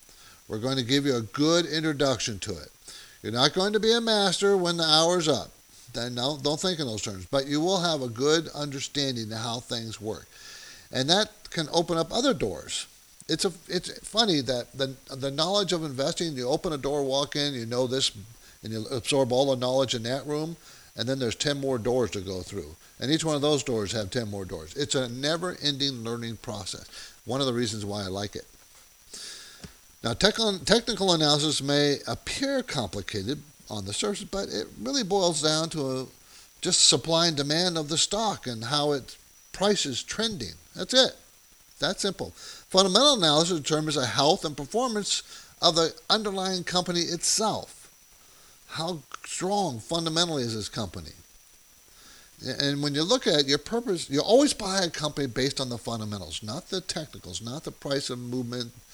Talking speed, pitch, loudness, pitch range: 185 wpm, 145 Hz, -26 LUFS, 120-170 Hz